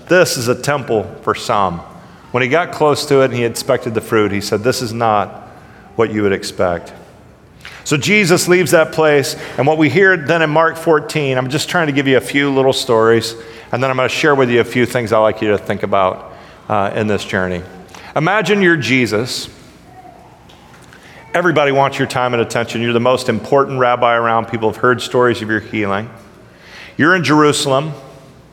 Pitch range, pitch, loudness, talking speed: 115-150 Hz, 130 Hz, -14 LUFS, 200 wpm